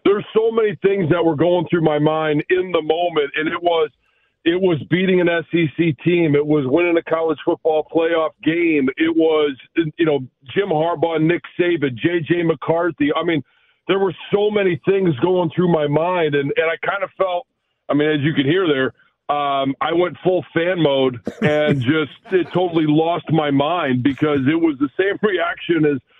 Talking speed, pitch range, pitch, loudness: 190 wpm, 150-175 Hz, 165 Hz, -18 LUFS